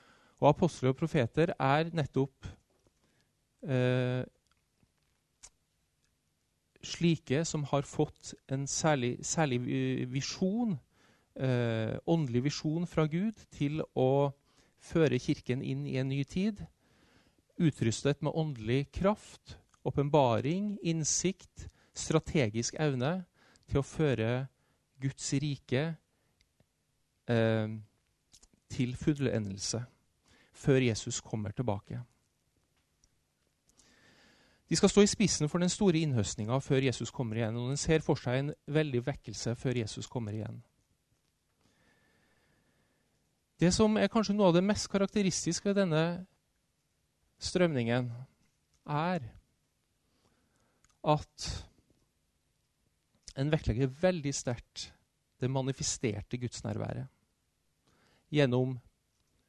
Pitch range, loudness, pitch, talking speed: 120-160 Hz, -32 LUFS, 135 Hz, 85 wpm